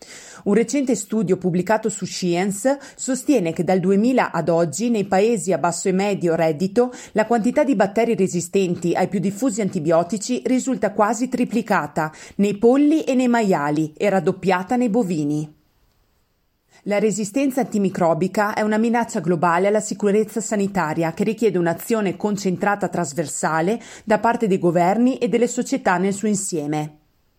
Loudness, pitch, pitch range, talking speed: -20 LUFS, 205 Hz, 175-230 Hz, 140 wpm